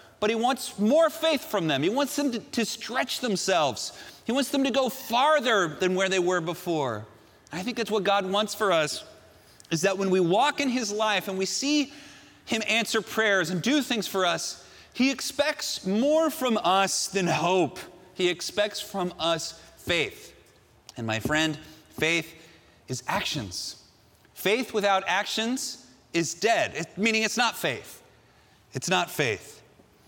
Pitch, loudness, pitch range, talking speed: 200 Hz, -26 LUFS, 170-250 Hz, 165 wpm